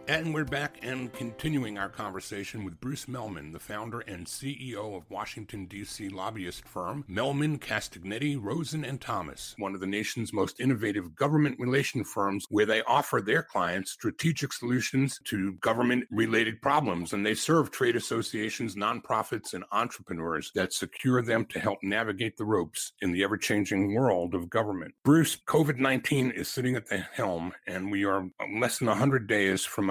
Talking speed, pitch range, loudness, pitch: 160 wpm, 100-135 Hz, -30 LUFS, 115 Hz